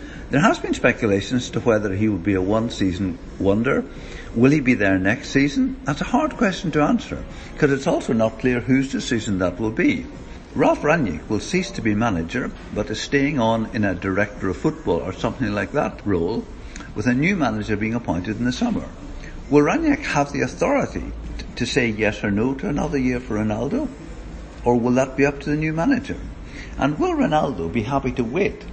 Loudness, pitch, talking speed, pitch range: -21 LUFS, 125 Hz, 200 wpm, 105-145 Hz